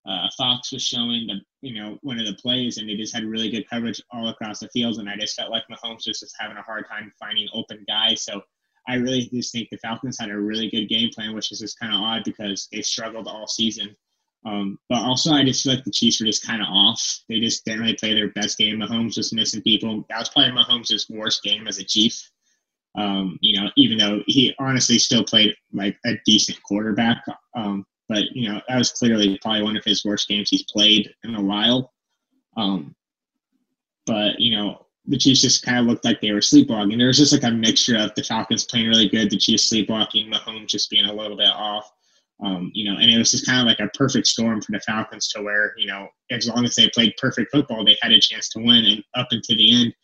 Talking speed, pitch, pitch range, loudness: 240 wpm, 110 Hz, 105-120 Hz, -19 LUFS